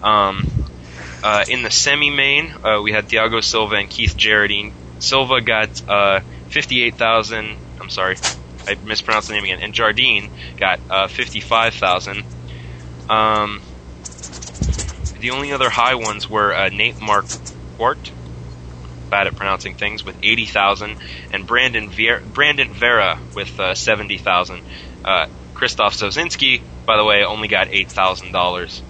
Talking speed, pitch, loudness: 135 wpm, 90 Hz, -17 LUFS